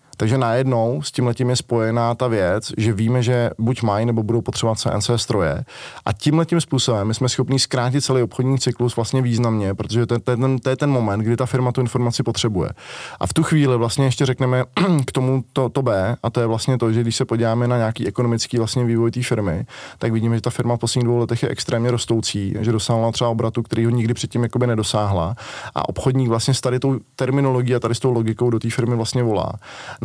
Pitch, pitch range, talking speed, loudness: 120 Hz, 115-130 Hz, 225 wpm, -20 LUFS